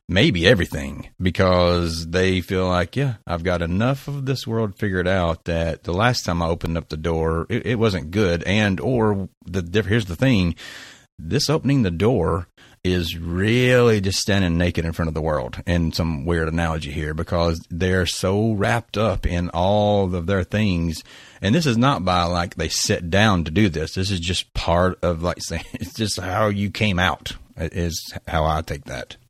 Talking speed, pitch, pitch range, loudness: 190 wpm, 90 Hz, 85-105 Hz, -21 LUFS